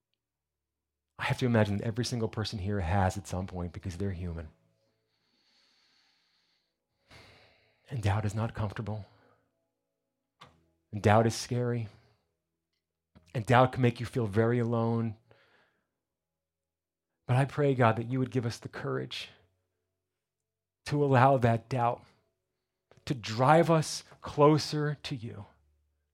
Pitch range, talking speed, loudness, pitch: 85-120 Hz, 125 wpm, -29 LUFS, 110 Hz